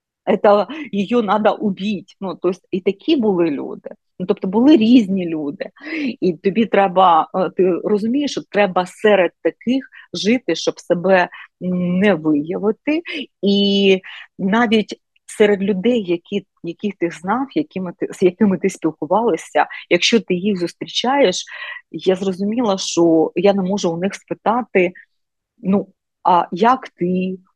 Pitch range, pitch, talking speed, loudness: 180-215 Hz, 195 Hz, 130 wpm, -18 LUFS